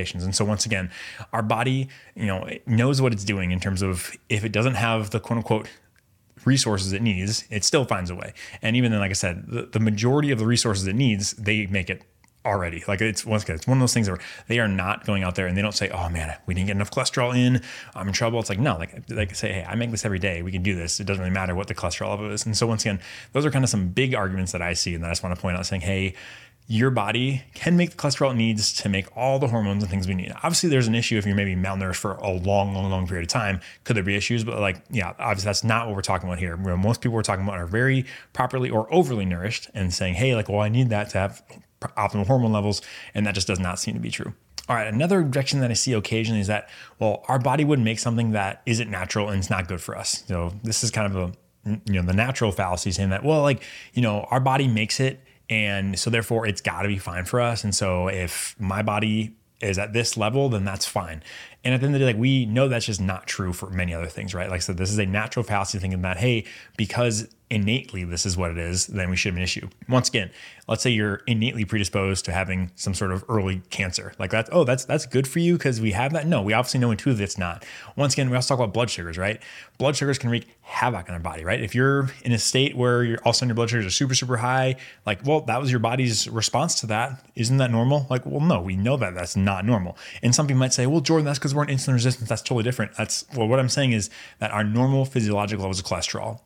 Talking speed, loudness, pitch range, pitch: 270 wpm, -24 LUFS, 95-125 Hz, 110 Hz